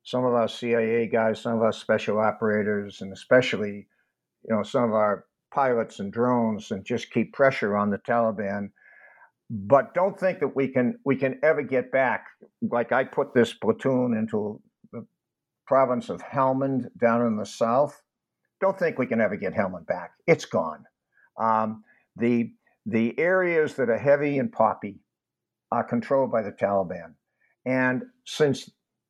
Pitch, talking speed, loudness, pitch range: 120 Hz, 160 wpm, -25 LUFS, 110-135 Hz